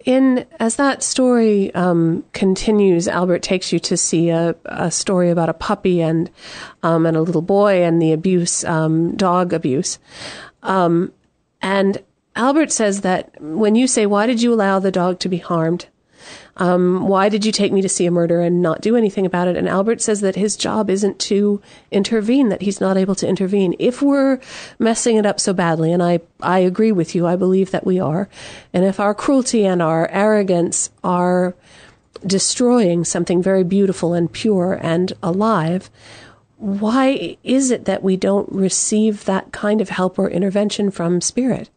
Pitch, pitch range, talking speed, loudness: 190 Hz, 175-210 Hz, 180 wpm, -17 LUFS